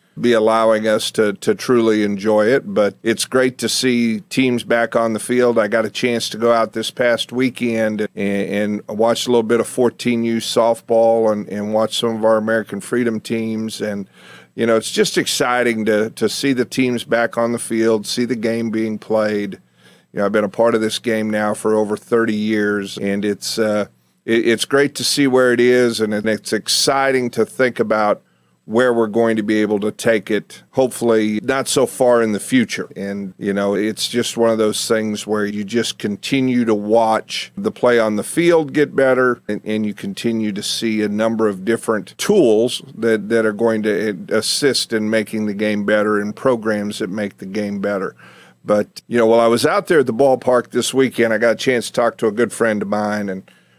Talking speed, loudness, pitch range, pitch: 215 wpm, -17 LUFS, 105-120 Hz, 110 Hz